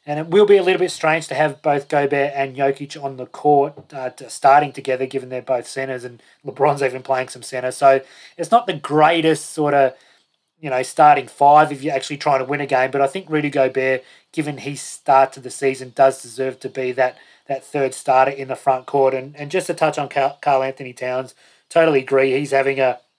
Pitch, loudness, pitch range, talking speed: 135 Hz, -18 LUFS, 130-150 Hz, 225 wpm